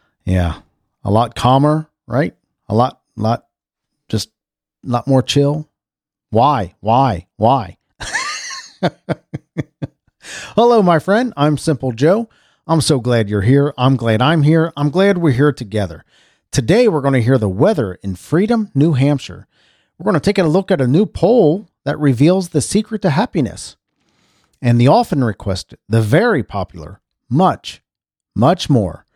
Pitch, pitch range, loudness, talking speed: 140 Hz, 115-160 Hz, -15 LUFS, 150 wpm